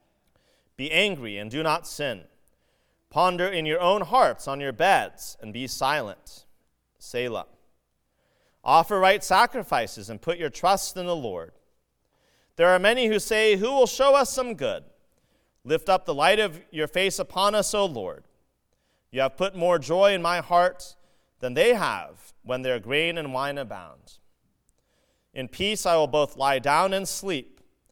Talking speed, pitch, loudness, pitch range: 165 wpm, 175 Hz, -24 LUFS, 135-200 Hz